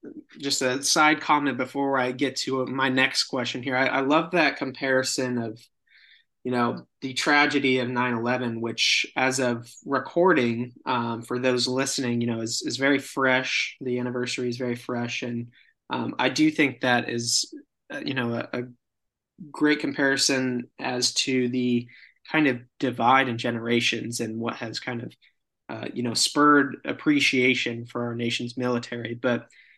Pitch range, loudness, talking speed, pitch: 120-135 Hz, -24 LUFS, 160 wpm, 125 Hz